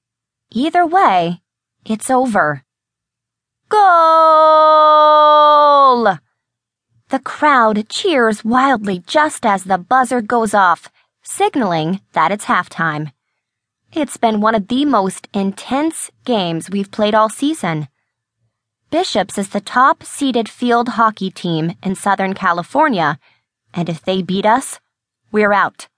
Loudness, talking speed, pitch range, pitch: -14 LUFS, 115 wpm, 170-270 Hz, 210 Hz